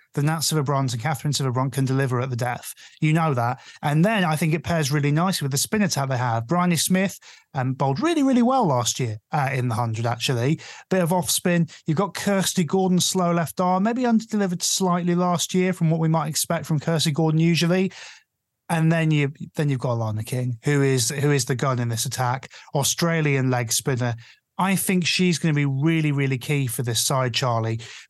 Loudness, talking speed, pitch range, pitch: -22 LUFS, 220 wpm, 130-175 Hz, 155 Hz